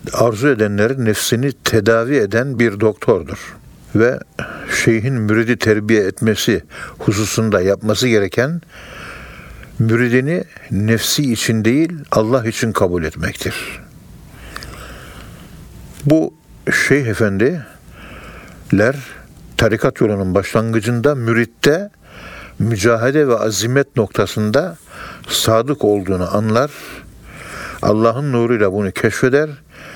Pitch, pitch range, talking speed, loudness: 115 Hz, 110-130 Hz, 80 wpm, -16 LUFS